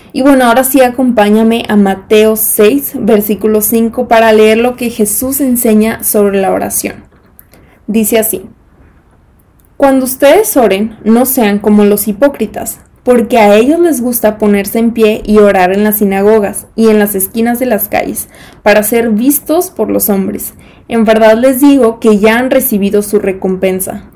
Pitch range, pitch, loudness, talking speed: 210-245 Hz, 220 Hz, -9 LUFS, 160 wpm